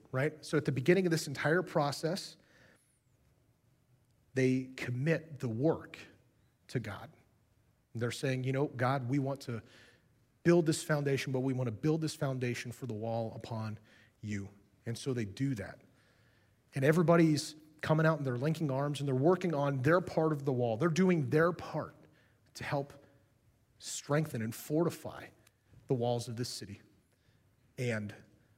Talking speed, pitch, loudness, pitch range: 160 wpm, 130 Hz, -33 LUFS, 115-150 Hz